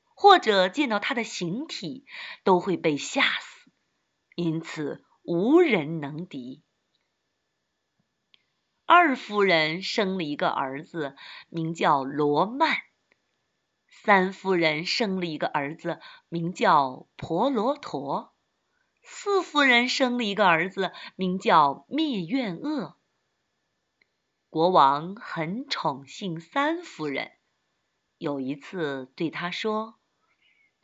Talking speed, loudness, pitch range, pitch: 145 characters per minute, -25 LUFS, 160-255 Hz, 185 Hz